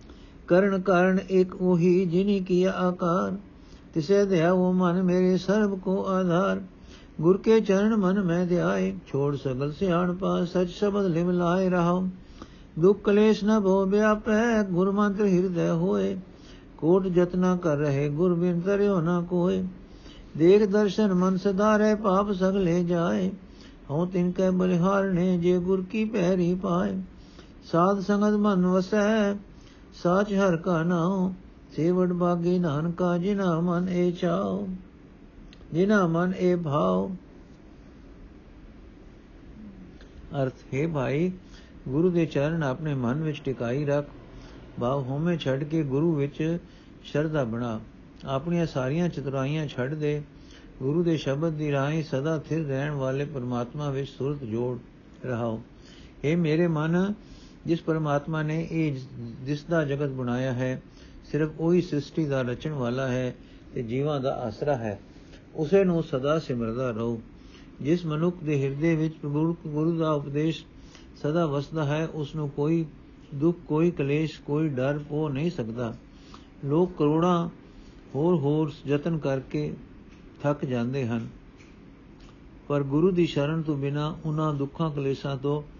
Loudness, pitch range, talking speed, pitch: -26 LUFS, 140-185 Hz, 135 wpm, 165 Hz